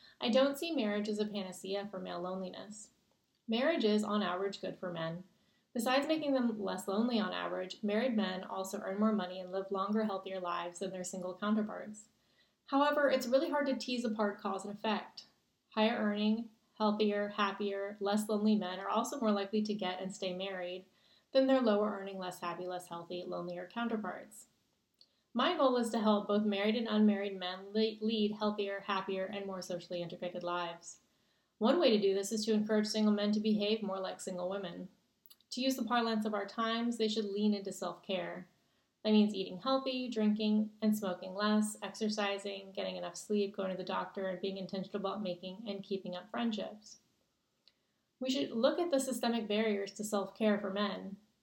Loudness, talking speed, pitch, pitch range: -35 LUFS, 185 wpm, 205 Hz, 190-220 Hz